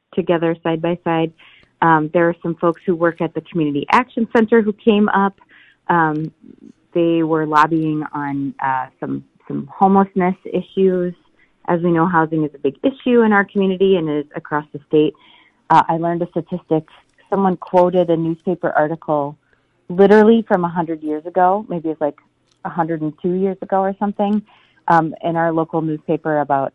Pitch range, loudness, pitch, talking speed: 155-190 Hz, -18 LUFS, 170 Hz, 175 wpm